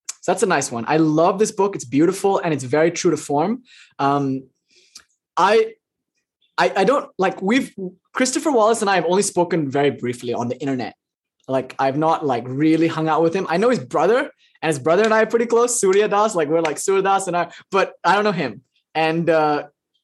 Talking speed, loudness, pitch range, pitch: 215 wpm, -19 LUFS, 150-210 Hz, 170 Hz